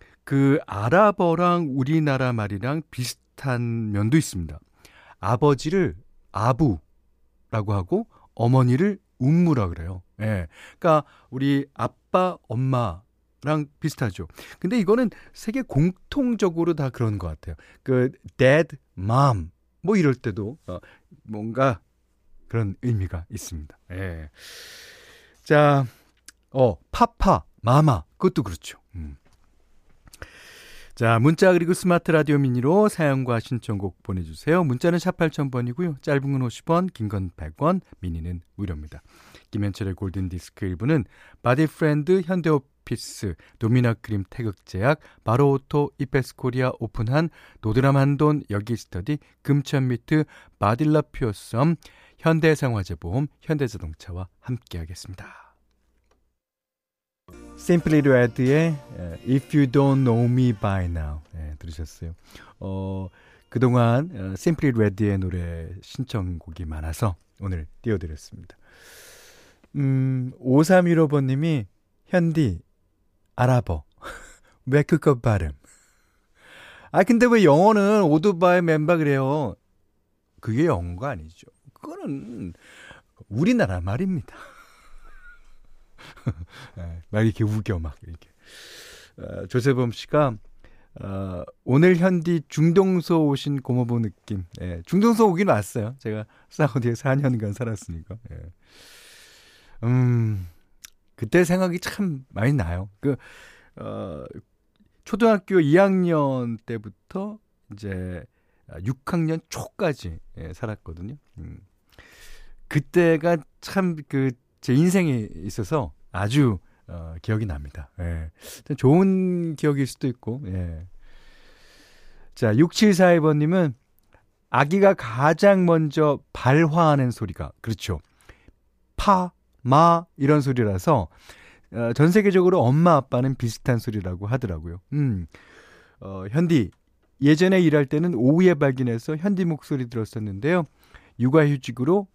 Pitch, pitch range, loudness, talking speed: 125 Hz, 95-155 Hz, -22 LUFS, 245 characters per minute